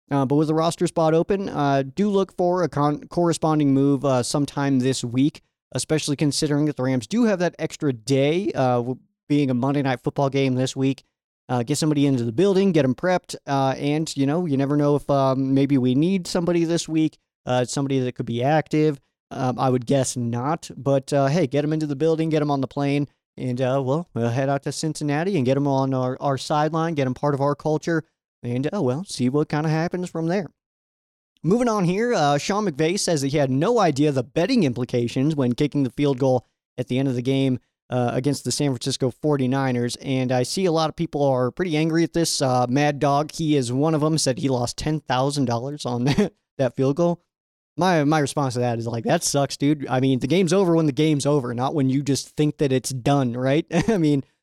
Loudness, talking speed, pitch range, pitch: -22 LUFS, 230 wpm, 130-155 Hz, 145 Hz